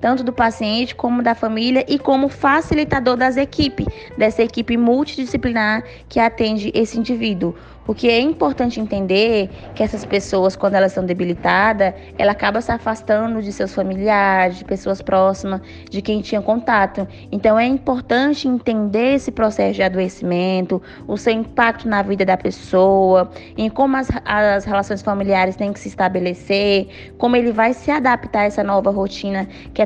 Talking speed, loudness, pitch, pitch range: 160 wpm, -18 LUFS, 215 Hz, 195-240 Hz